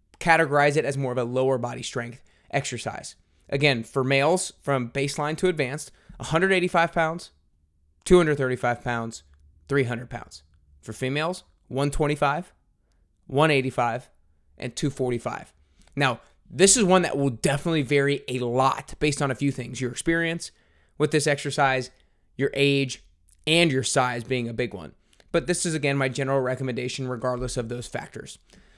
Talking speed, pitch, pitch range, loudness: 145 wpm, 135 Hz, 120-150 Hz, -24 LUFS